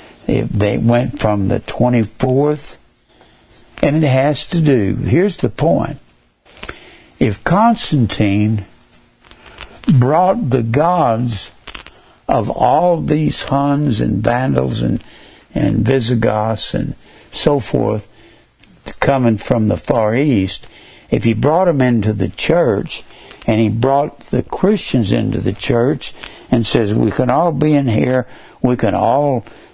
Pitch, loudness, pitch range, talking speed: 120 Hz, -15 LUFS, 110-140 Hz, 125 wpm